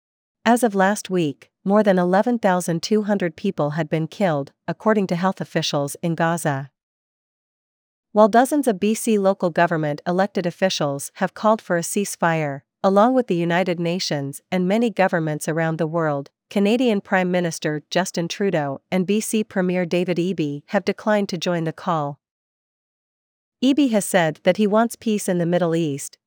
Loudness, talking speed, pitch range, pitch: -21 LUFS, 155 wpm, 165-205 Hz, 180 Hz